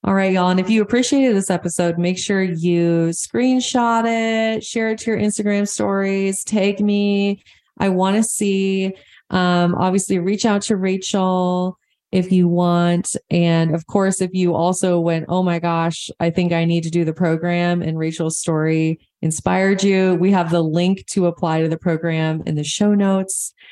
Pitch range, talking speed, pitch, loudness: 170-200 Hz, 180 wpm, 185 Hz, -18 LUFS